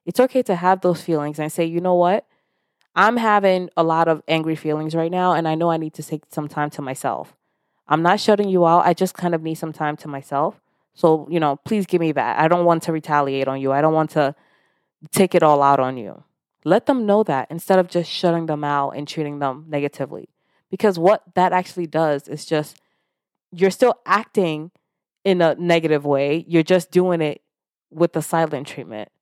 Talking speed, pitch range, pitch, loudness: 215 wpm, 150-180 Hz, 165 Hz, -19 LUFS